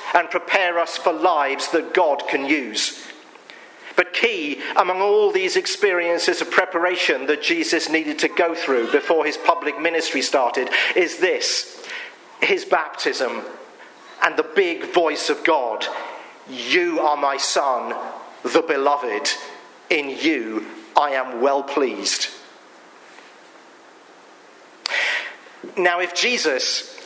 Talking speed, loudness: 120 wpm, -20 LUFS